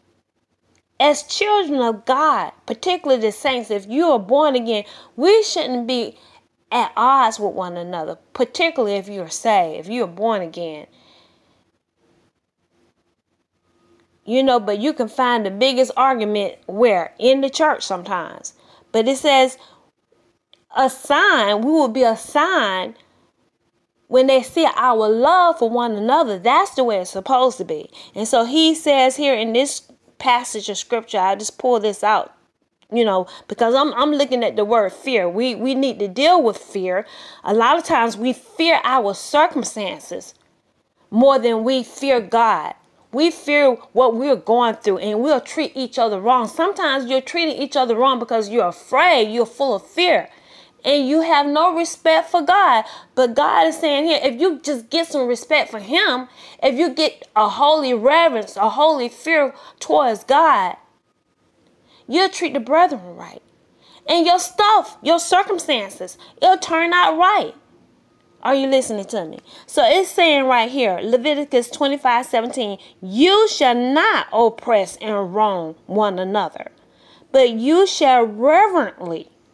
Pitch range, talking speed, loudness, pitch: 220-305 Hz, 160 wpm, -17 LUFS, 260 Hz